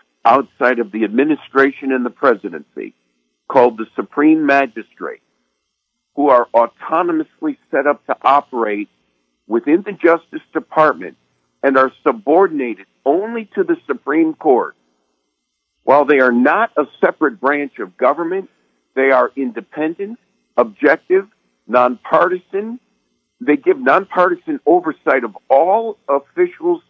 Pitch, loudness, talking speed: 145 Hz, -16 LUFS, 115 wpm